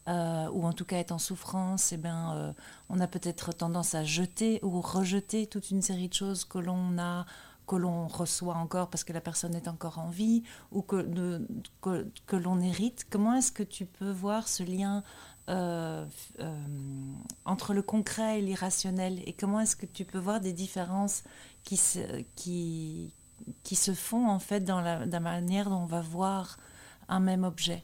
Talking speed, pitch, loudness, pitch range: 195 wpm, 180 Hz, -32 LUFS, 170-195 Hz